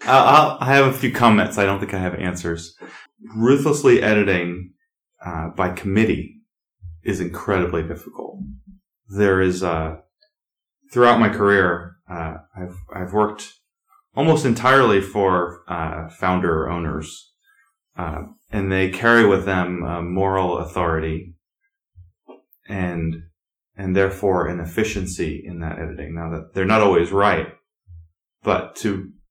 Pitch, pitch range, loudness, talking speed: 95 Hz, 85-115 Hz, -19 LUFS, 125 wpm